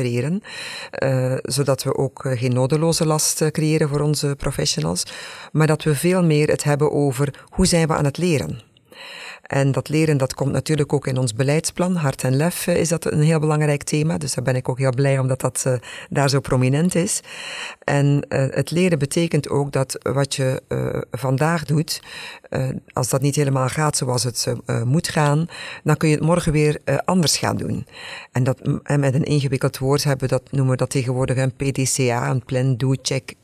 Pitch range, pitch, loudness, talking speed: 130-155 Hz, 140 Hz, -20 LUFS, 185 wpm